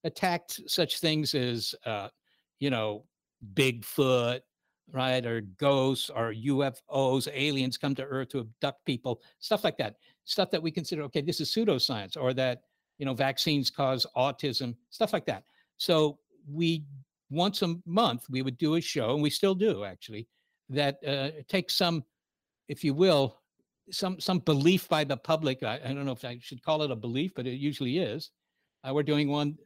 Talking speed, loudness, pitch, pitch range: 180 wpm, -29 LUFS, 140 Hz, 130-160 Hz